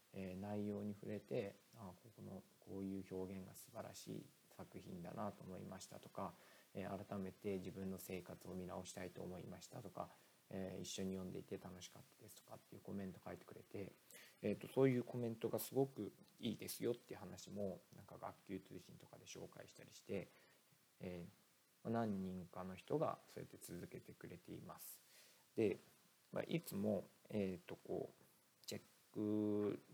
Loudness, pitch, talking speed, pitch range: -48 LUFS, 95 Hz, 335 characters per minute, 95-105 Hz